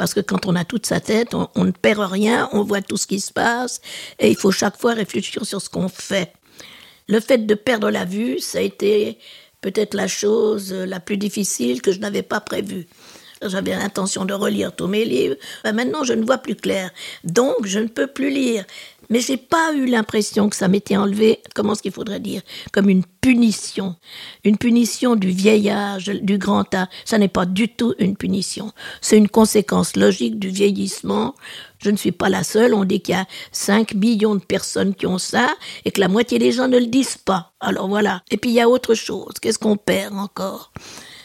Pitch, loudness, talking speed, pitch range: 205 Hz, -19 LUFS, 215 wpm, 195-225 Hz